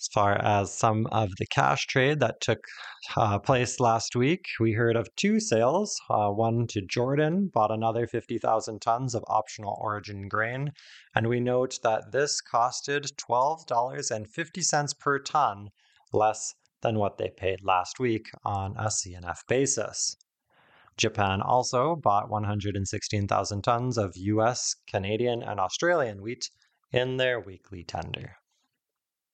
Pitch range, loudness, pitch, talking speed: 105-125 Hz, -27 LUFS, 115 Hz, 135 wpm